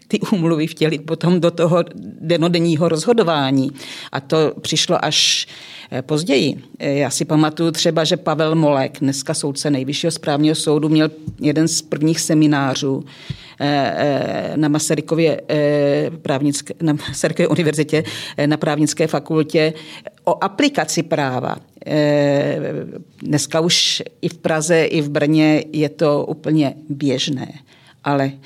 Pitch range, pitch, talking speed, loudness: 145-165 Hz, 155 Hz, 115 wpm, -18 LUFS